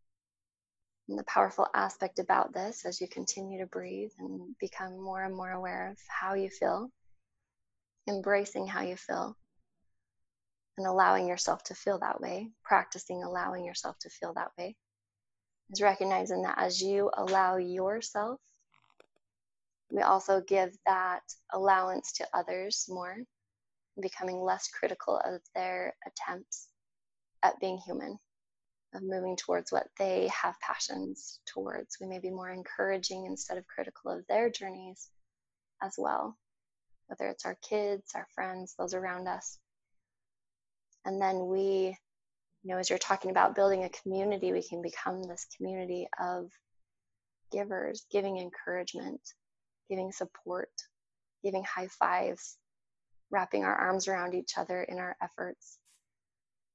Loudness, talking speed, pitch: -33 LUFS, 135 wpm, 185 Hz